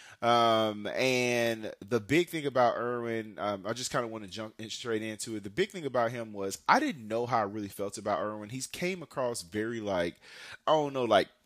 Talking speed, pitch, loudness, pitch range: 220 wpm, 115 Hz, -31 LUFS, 105-125 Hz